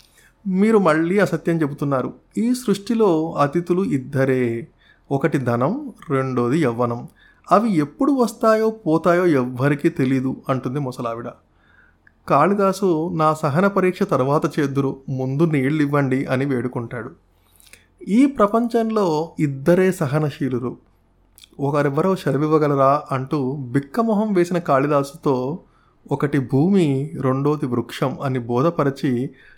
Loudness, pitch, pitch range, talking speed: -20 LUFS, 145 Hz, 130-175 Hz, 95 wpm